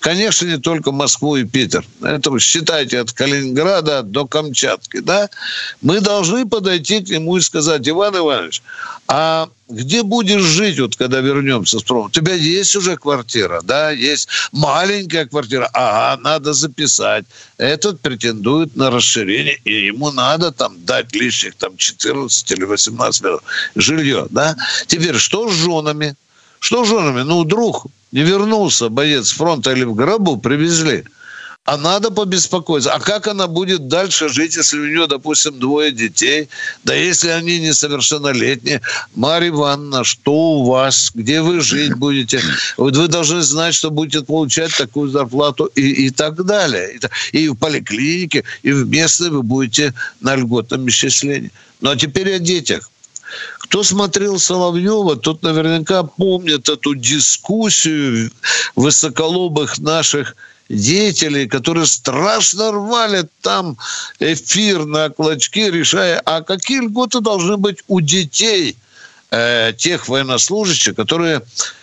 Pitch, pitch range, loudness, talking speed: 155 Hz, 140-180 Hz, -14 LUFS, 140 wpm